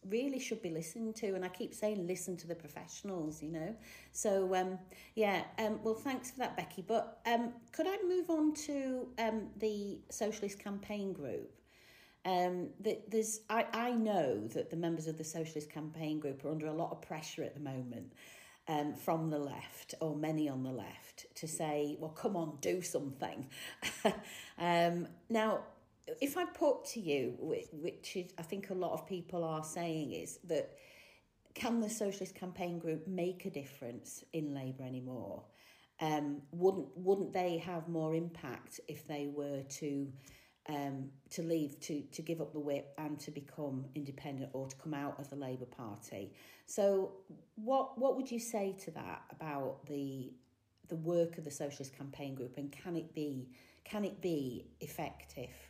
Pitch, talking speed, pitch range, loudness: 170 Hz, 175 wpm, 145-210 Hz, -39 LUFS